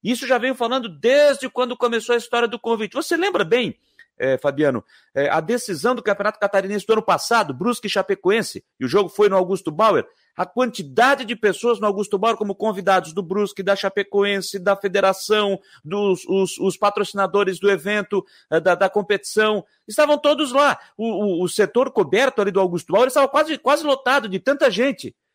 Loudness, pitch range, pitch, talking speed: -20 LUFS, 195-245 Hz, 210 Hz, 185 wpm